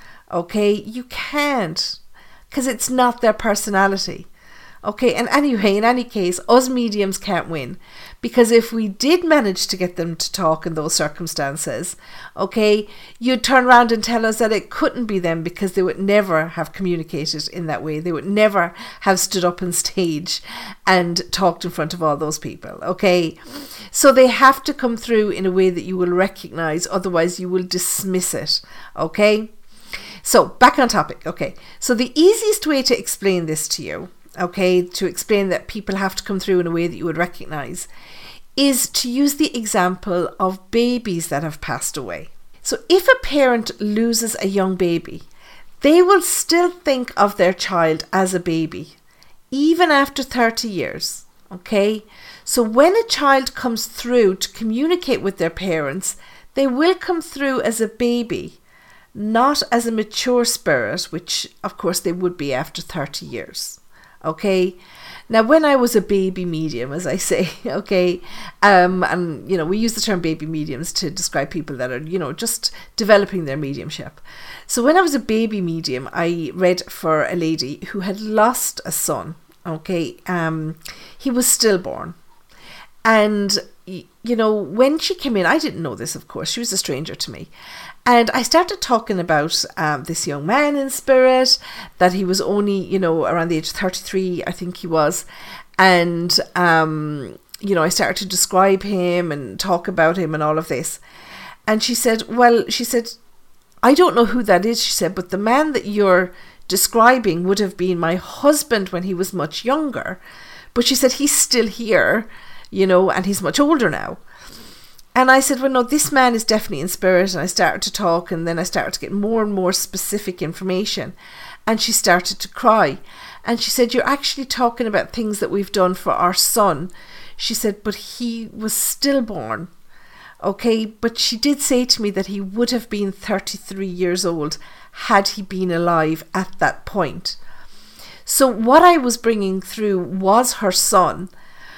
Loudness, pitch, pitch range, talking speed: -18 LUFS, 200 Hz, 180-240 Hz, 180 wpm